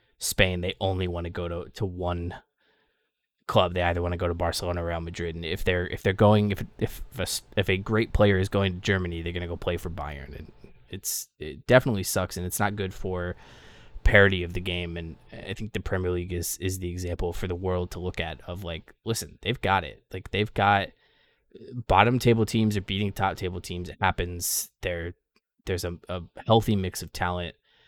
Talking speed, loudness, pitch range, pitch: 215 wpm, -27 LUFS, 85-100 Hz, 90 Hz